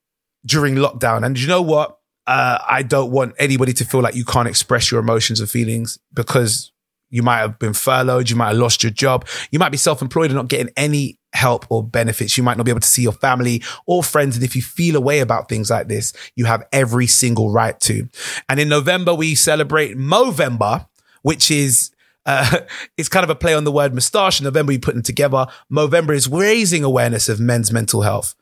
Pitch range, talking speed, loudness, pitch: 120-150 Hz, 215 wpm, -16 LUFS, 130 Hz